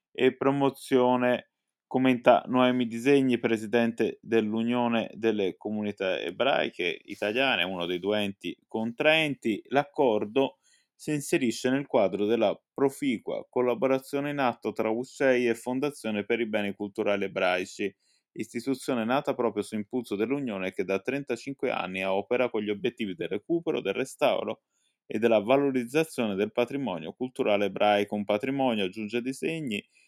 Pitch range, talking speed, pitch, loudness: 105-135 Hz, 130 wpm, 120 Hz, -28 LUFS